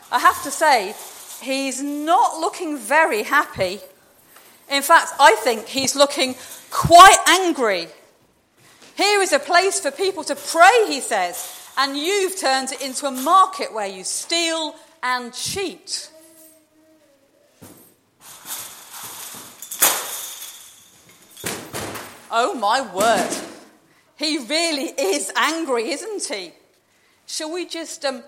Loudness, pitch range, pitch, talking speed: -18 LUFS, 275-340 Hz, 310 Hz, 110 wpm